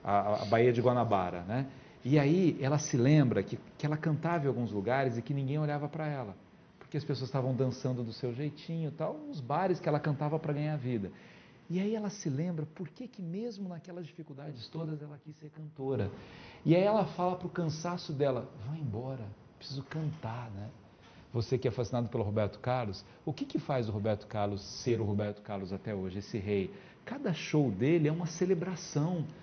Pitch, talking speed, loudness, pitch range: 140 Hz, 200 wpm, -33 LUFS, 115-160 Hz